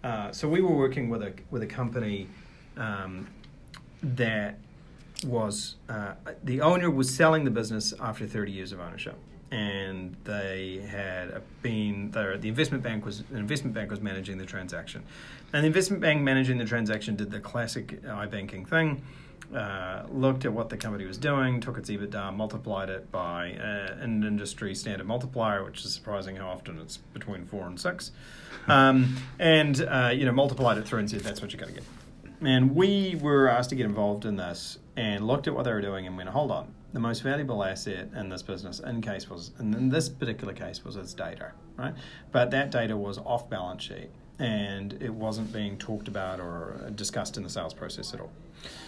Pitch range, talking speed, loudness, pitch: 100-130 Hz, 195 wpm, -29 LUFS, 110 Hz